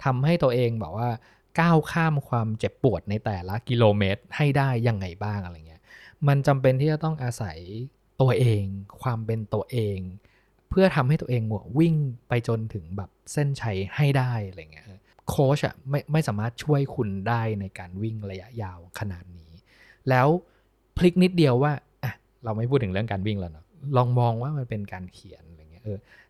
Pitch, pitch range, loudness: 115 Hz, 100-140 Hz, -25 LUFS